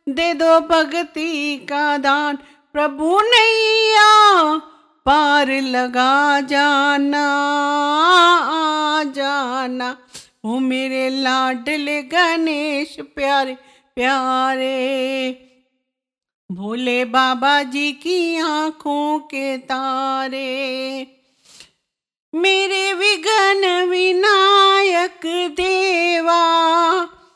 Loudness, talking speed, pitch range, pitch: -16 LUFS, 65 wpm, 265-340 Hz, 290 Hz